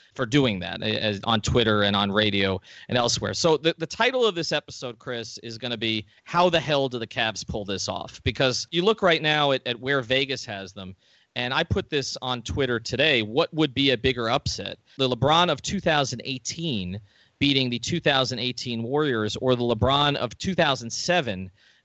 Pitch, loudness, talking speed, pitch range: 125 Hz, -24 LUFS, 190 wpm, 110-145 Hz